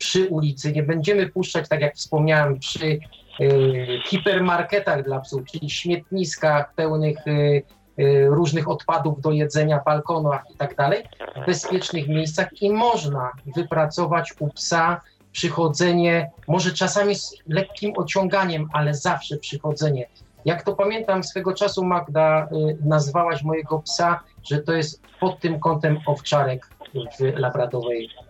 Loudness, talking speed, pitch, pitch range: -22 LUFS, 130 wpm, 155 Hz, 145-175 Hz